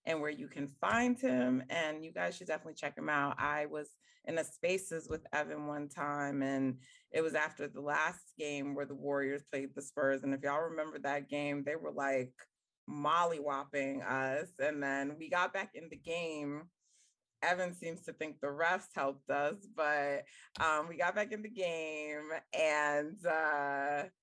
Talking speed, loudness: 185 wpm, -37 LUFS